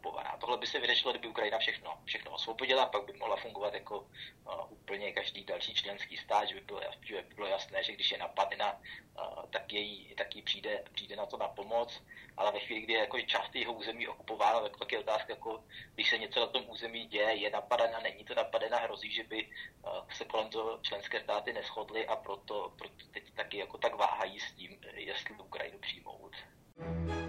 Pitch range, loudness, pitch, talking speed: 100-115 Hz, -36 LUFS, 110 Hz, 205 wpm